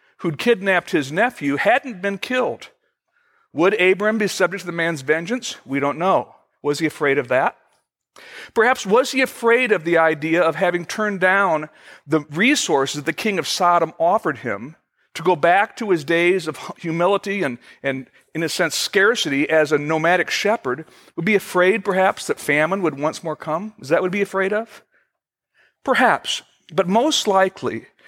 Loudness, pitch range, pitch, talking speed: -19 LUFS, 160-205 Hz, 180 Hz, 175 wpm